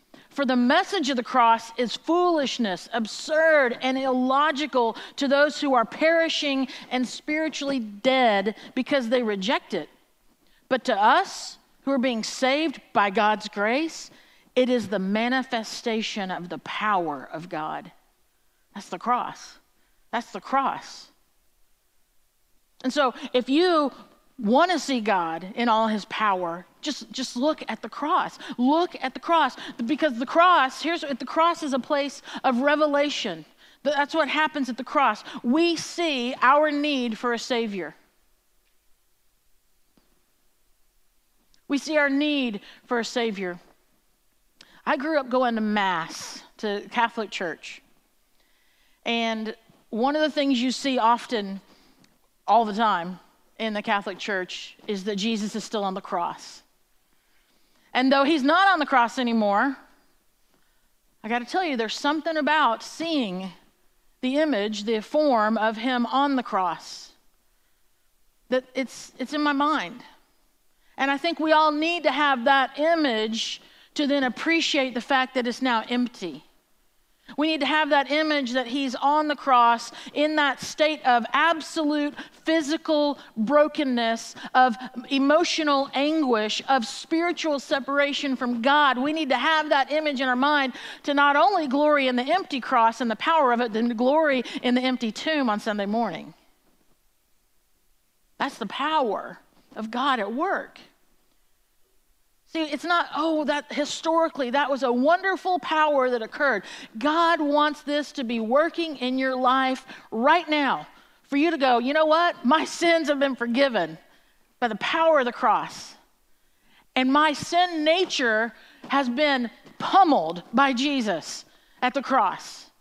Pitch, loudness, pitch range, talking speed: 270 Hz, -24 LUFS, 235-300 Hz, 150 wpm